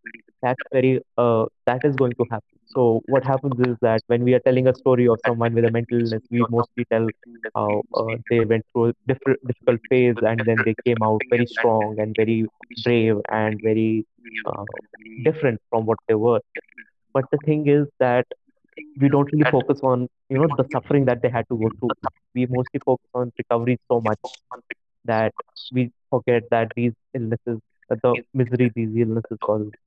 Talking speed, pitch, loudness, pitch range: 190 wpm, 120 Hz, -21 LUFS, 115-130 Hz